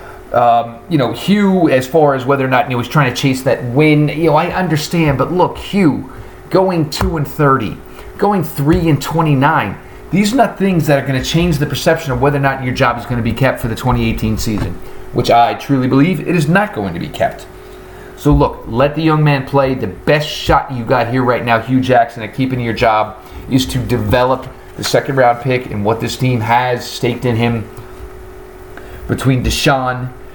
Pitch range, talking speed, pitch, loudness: 120-150 Hz, 210 wpm, 130 Hz, -14 LUFS